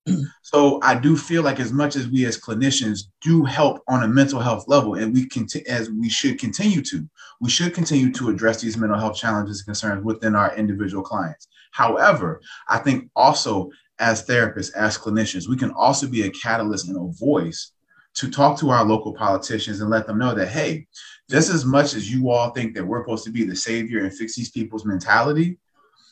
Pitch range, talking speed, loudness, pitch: 110-145 Hz, 205 wpm, -21 LUFS, 120 Hz